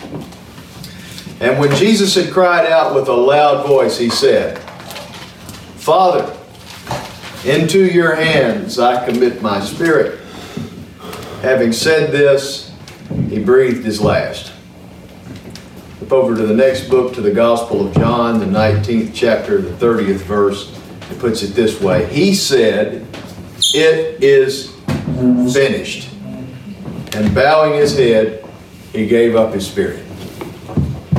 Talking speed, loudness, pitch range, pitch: 120 wpm, -14 LUFS, 110-170 Hz, 130 Hz